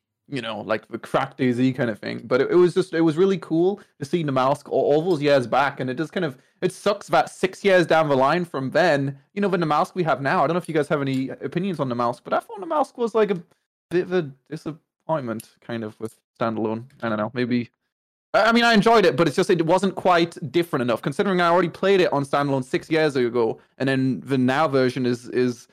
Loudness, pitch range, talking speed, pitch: -22 LUFS, 130-180 Hz, 260 wpm, 155 Hz